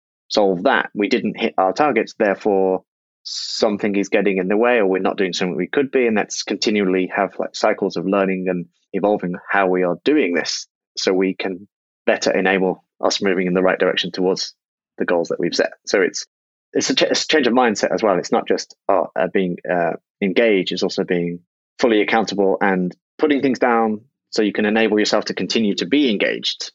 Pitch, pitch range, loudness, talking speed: 95 Hz, 90-105 Hz, -19 LUFS, 210 wpm